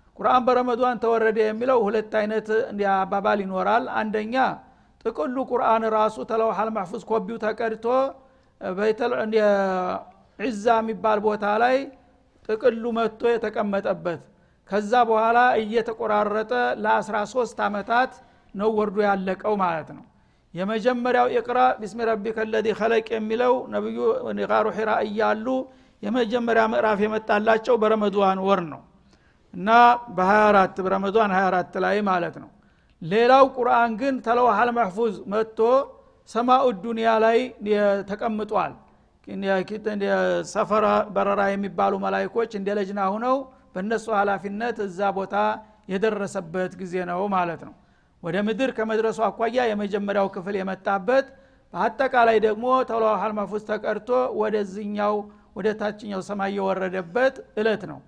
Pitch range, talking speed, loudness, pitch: 200-235 Hz, 105 wpm, -23 LUFS, 215 Hz